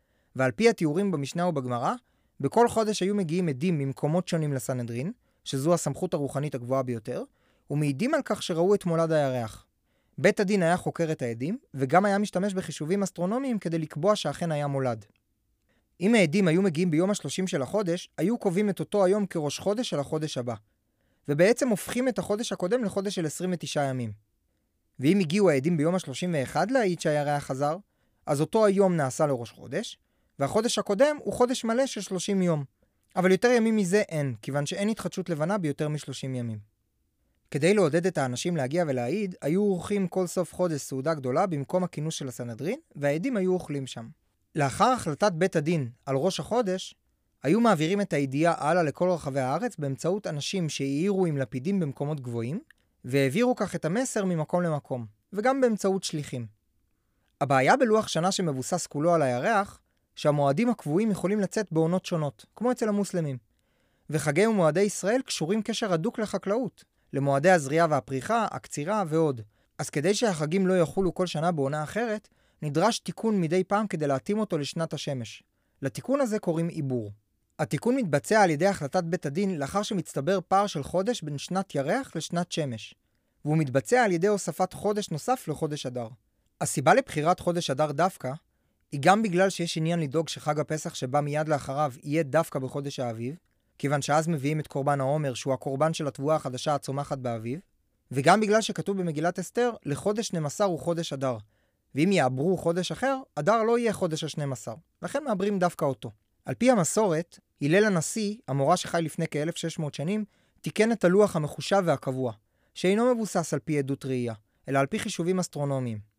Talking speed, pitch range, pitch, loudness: 160 wpm, 140-195 Hz, 165 Hz, -27 LUFS